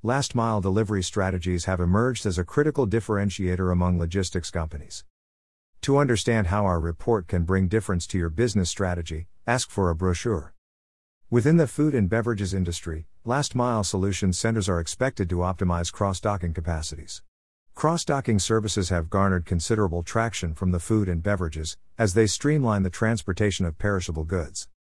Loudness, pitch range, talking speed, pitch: -25 LUFS, 85-110 Hz, 155 wpm, 95 Hz